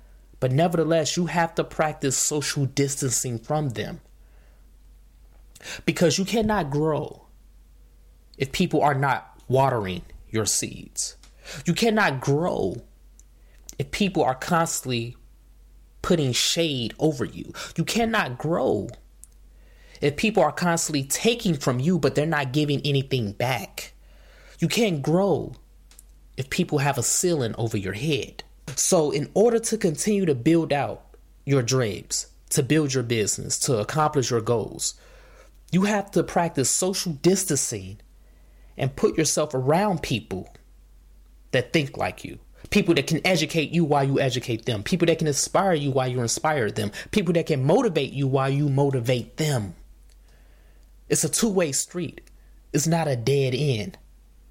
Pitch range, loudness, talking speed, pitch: 105-165 Hz, -24 LUFS, 140 wpm, 140 Hz